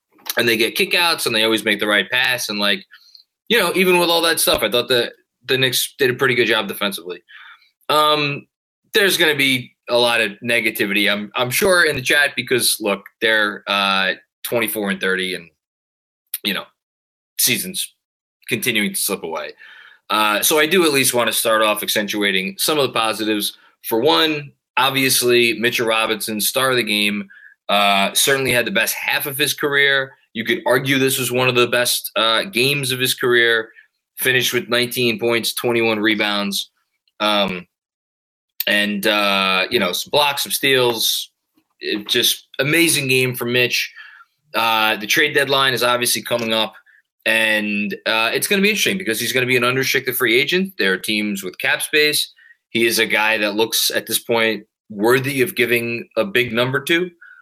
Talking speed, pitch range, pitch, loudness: 185 wpm, 105-135 Hz, 120 Hz, -17 LUFS